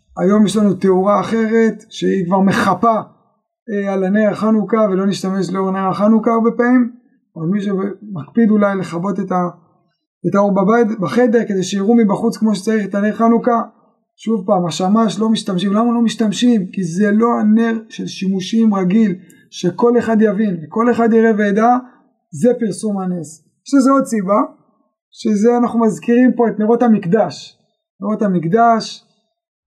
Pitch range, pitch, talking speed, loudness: 195-230 Hz, 215 Hz, 150 wpm, -15 LUFS